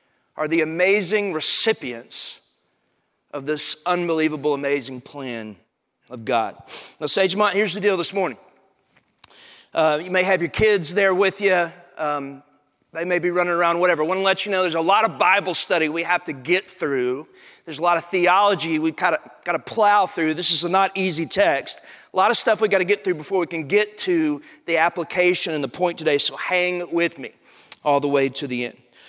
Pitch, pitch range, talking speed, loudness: 175 Hz, 155-195 Hz, 200 wpm, -20 LUFS